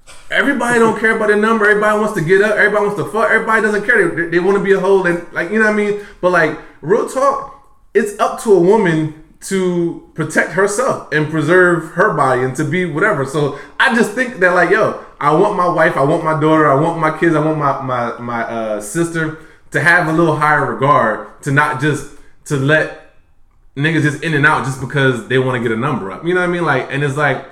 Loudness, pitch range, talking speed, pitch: -14 LUFS, 145-200 Hz, 245 wpm, 160 Hz